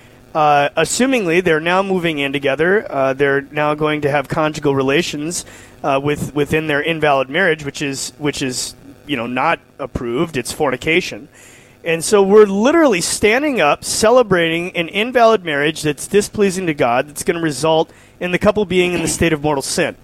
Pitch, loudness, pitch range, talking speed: 155 Hz, -16 LUFS, 140-180 Hz, 175 wpm